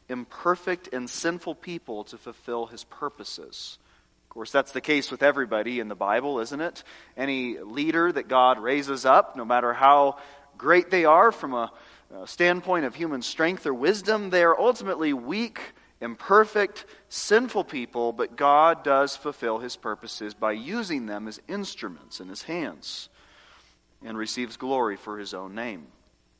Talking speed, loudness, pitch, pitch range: 155 wpm, -25 LUFS, 135 Hz, 115-170 Hz